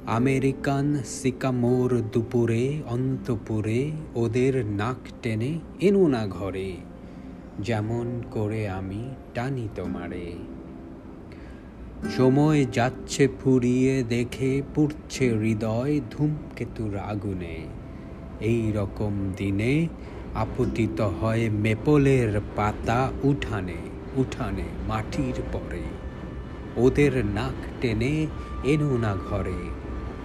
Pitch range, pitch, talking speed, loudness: 95-130 Hz, 115 Hz, 80 wpm, -26 LUFS